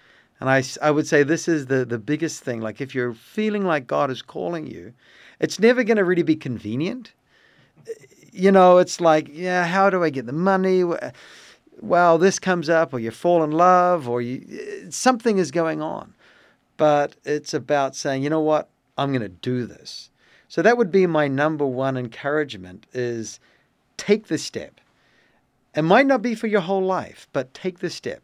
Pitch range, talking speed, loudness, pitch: 135-185 Hz, 190 wpm, -21 LUFS, 160 Hz